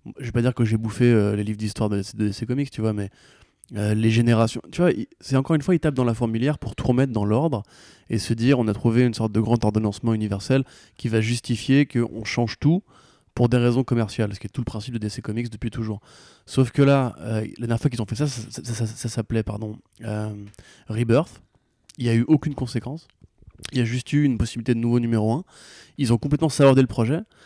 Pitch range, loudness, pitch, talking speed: 110-130 Hz, -23 LUFS, 120 Hz, 250 wpm